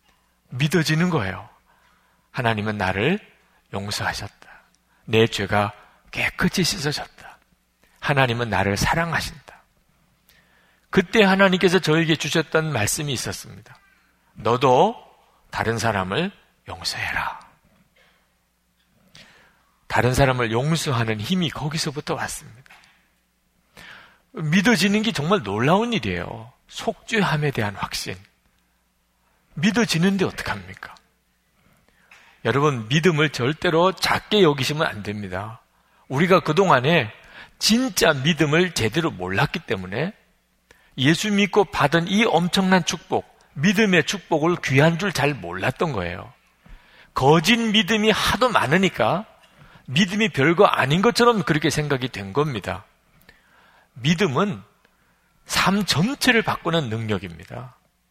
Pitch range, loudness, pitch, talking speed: 115-190 Hz, -21 LUFS, 155 Hz, 245 characters per minute